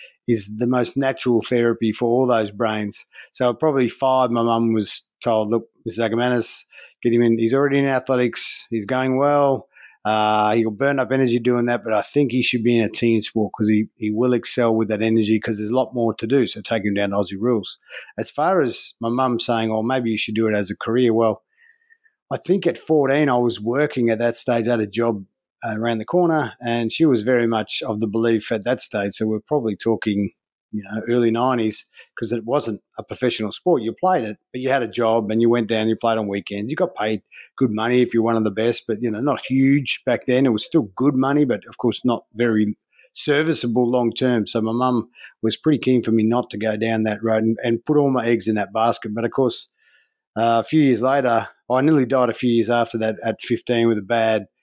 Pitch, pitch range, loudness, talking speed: 115 Hz, 110-130 Hz, -20 LUFS, 240 wpm